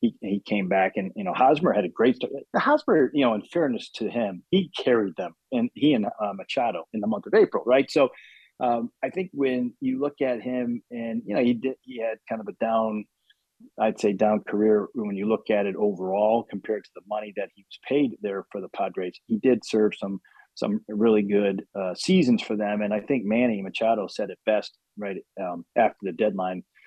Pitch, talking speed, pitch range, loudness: 110 Hz, 220 wpm, 105-125 Hz, -25 LUFS